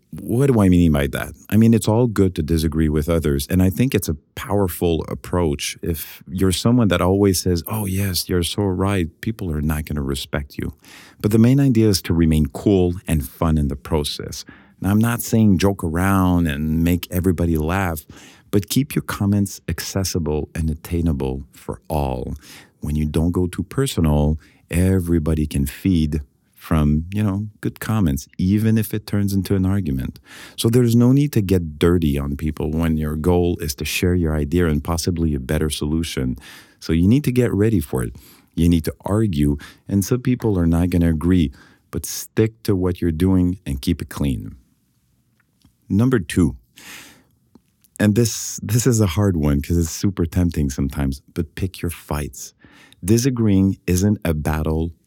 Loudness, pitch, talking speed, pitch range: -20 LUFS, 90 Hz, 180 wpm, 80-100 Hz